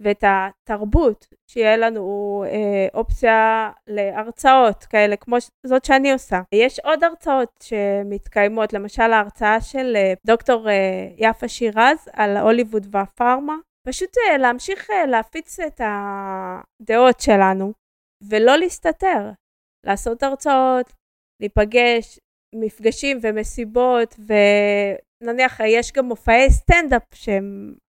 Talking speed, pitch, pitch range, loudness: 95 wpm, 225 Hz, 205-255 Hz, -18 LUFS